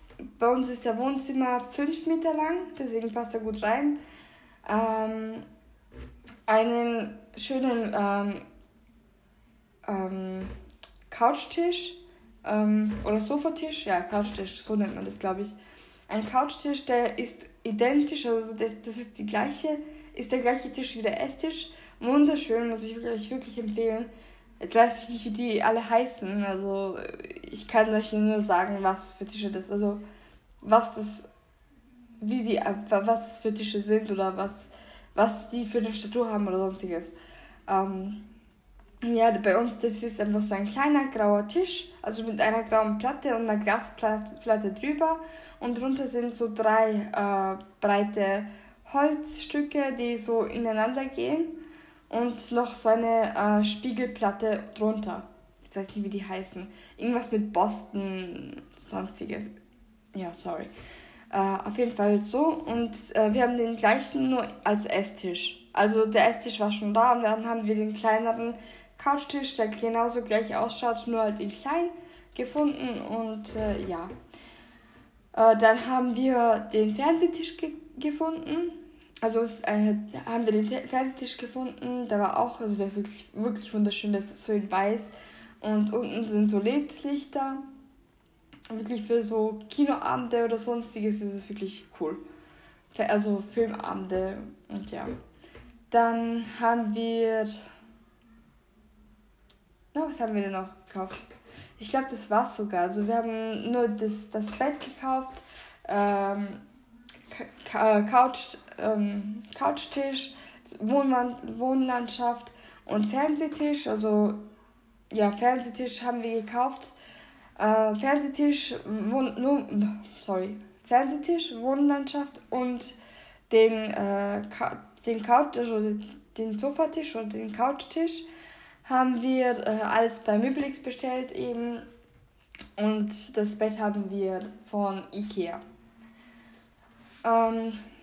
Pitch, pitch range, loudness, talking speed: 225 Hz, 210-255 Hz, -28 LUFS, 135 wpm